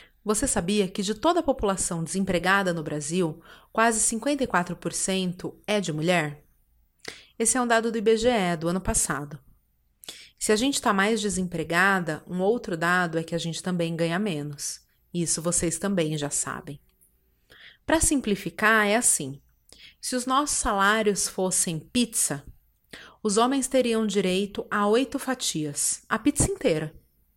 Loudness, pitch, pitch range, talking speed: -25 LUFS, 190 Hz, 165-225 Hz, 145 wpm